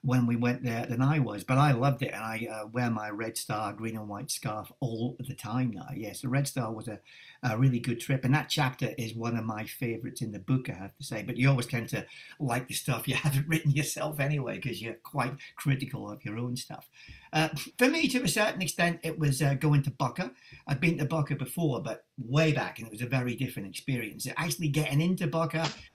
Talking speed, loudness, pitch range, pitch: 240 wpm, -30 LUFS, 120-150 Hz, 130 Hz